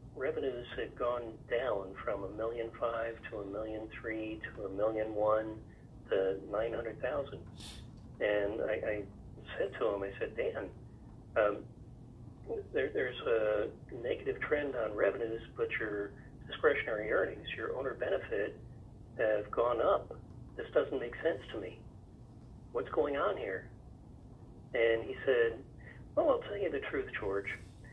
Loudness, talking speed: -36 LUFS, 145 wpm